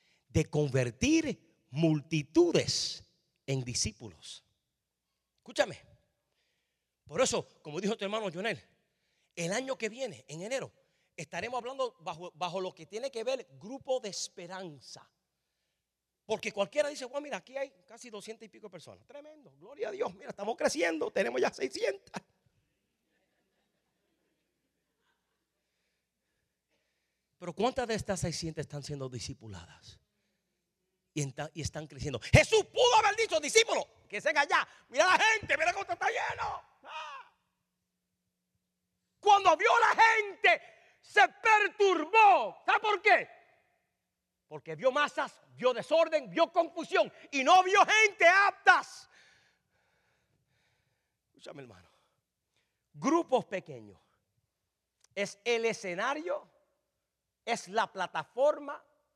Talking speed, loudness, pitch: 115 wpm, -29 LUFS, 230 Hz